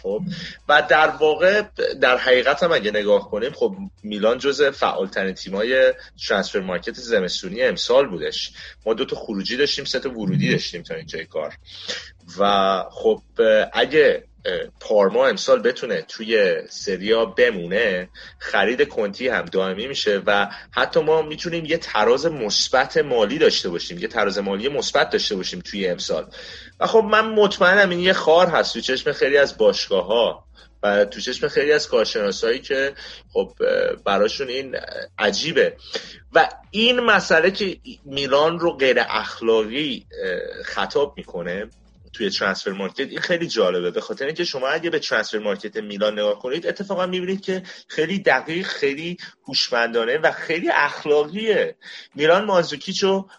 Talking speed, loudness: 145 wpm, -20 LUFS